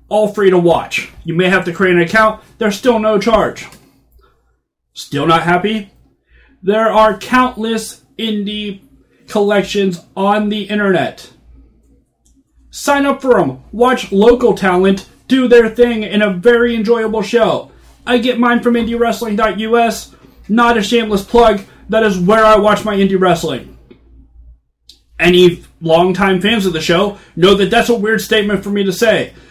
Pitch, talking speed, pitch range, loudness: 210 Hz, 150 wpm, 185-230 Hz, -13 LUFS